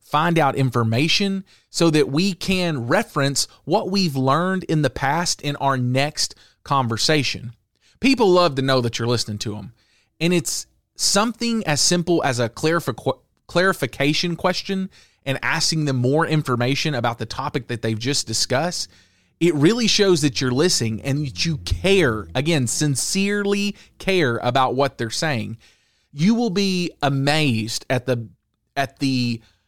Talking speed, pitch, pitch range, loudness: 150 wpm, 140 Hz, 120-175 Hz, -20 LUFS